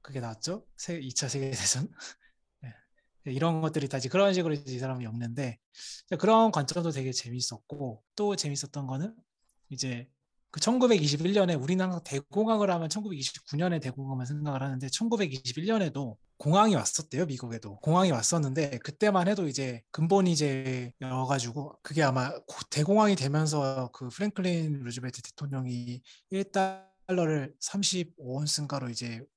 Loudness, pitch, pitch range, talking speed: -30 LUFS, 145 Hz, 130-185 Hz, 300 characters per minute